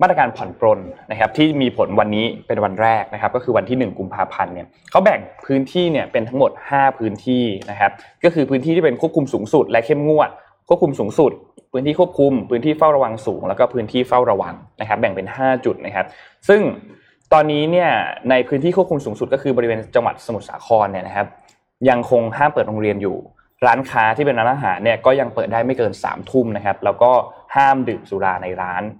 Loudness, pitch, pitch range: -18 LUFS, 125 Hz, 110-150 Hz